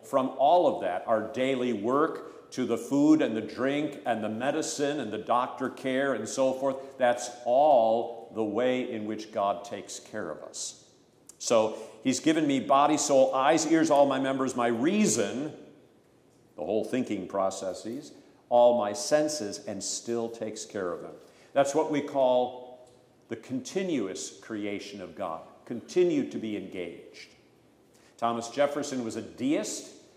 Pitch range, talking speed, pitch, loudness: 115-145 Hz, 155 wpm, 125 Hz, -28 LUFS